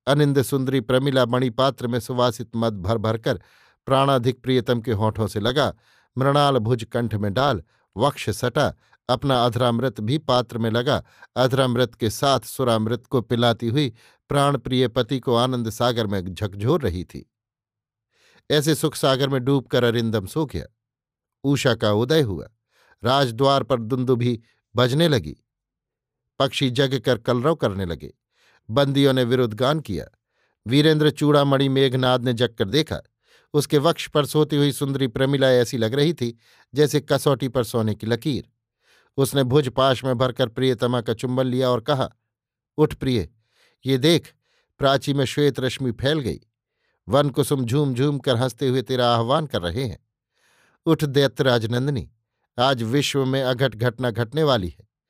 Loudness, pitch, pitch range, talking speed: -22 LUFS, 130 Hz, 120-140 Hz, 150 wpm